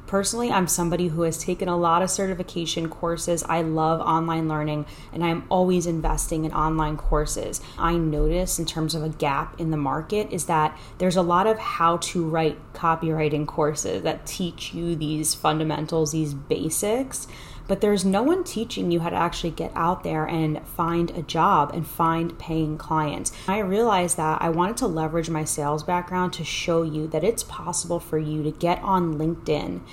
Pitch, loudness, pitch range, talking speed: 165 Hz, -24 LUFS, 155-175 Hz, 185 wpm